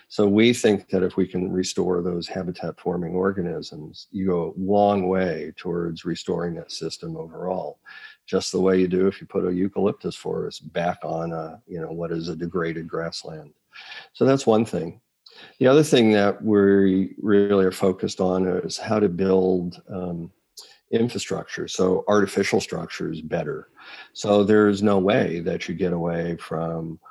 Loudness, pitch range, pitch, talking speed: -23 LUFS, 85-100 Hz, 95 Hz, 165 wpm